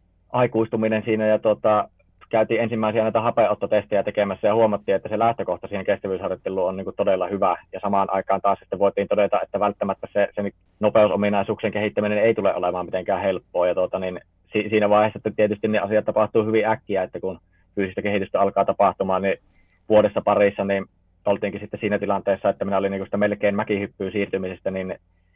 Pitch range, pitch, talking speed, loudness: 95-110 Hz, 100 Hz, 175 wpm, -22 LUFS